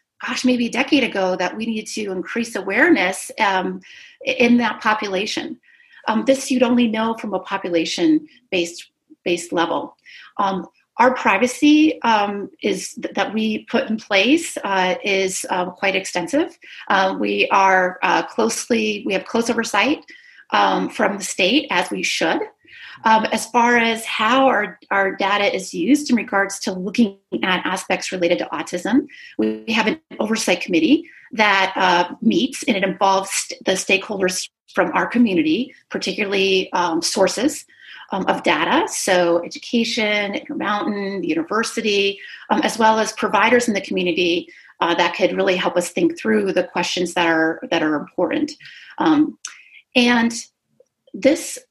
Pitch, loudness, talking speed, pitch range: 220 Hz, -19 LUFS, 150 wpm, 190-270 Hz